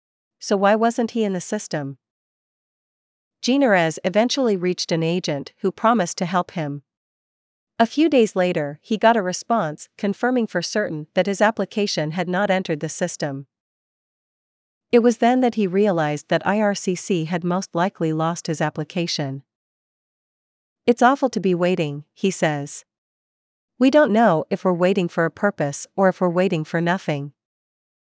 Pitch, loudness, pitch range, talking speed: 180 Hz, -21 LUFS, 160-210 Hz, 155 wpm